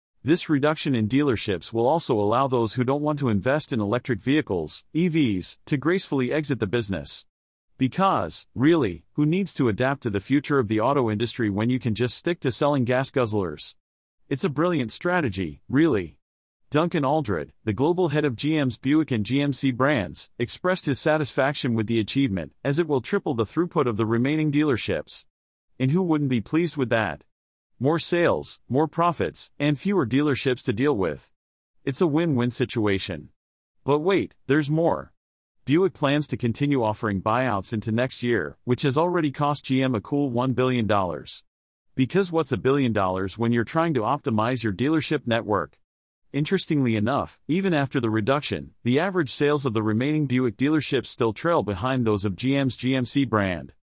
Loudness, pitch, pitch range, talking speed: -24 LUFS, 130 Hz, 115-150 Hz, 170 wpm